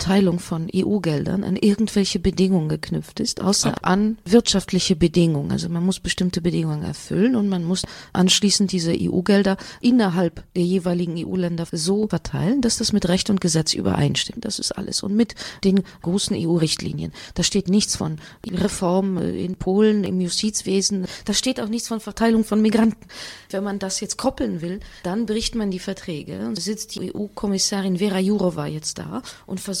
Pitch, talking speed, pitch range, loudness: 190 Hz, 165 wpm, 175-210 Hz, -21 LUFS